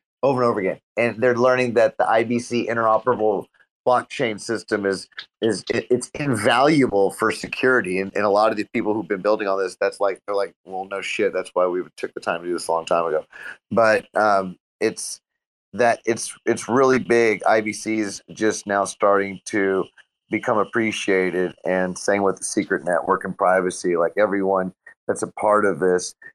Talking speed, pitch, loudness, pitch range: 185 wpm, 100 Hz, -21 LUFS, 95-115 Hz